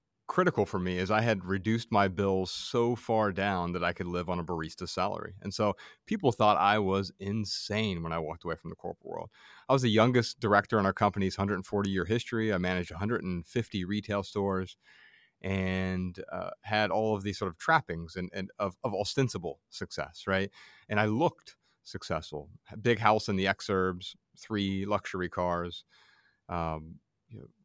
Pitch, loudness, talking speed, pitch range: 100 Hz, -31 LUFS, 180 wpm, 90-110 Hz